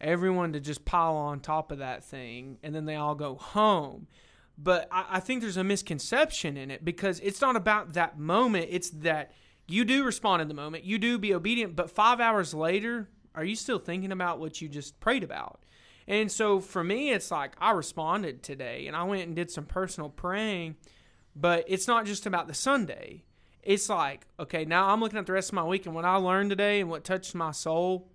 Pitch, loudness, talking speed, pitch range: 180 Hz, -29 LUFS, 215 wpm, 155-205 Hz